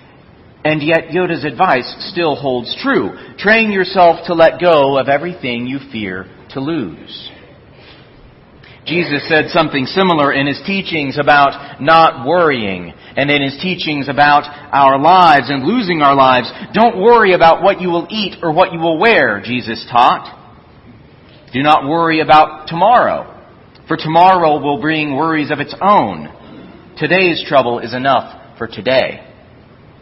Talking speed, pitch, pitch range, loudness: 145 wpm, 155 Hz, 135-175 Hz, -13 LUFS